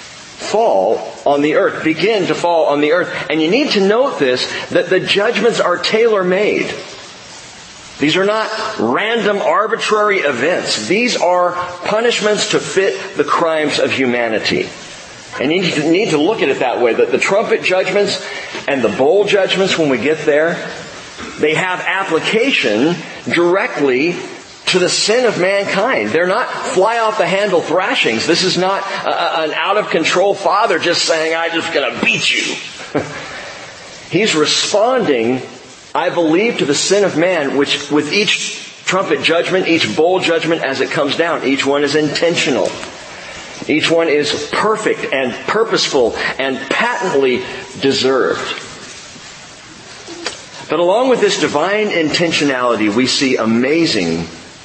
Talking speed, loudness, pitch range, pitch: 150 wpm, -14 LUFS, 150-210 Hz, 175 Hz